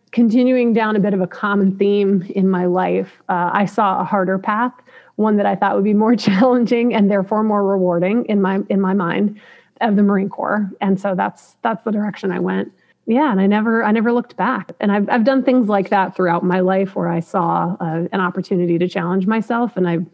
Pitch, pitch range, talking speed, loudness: 200 Hz, 190-220 Hz, 225 wpm, -17 LUFS